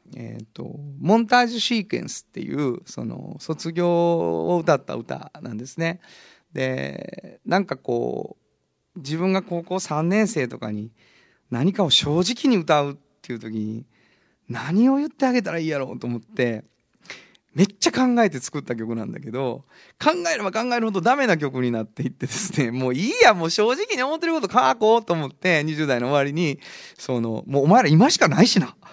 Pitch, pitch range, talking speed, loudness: 160 Hz, 125-200 Hz, 335 characters per minute, -22 LUFS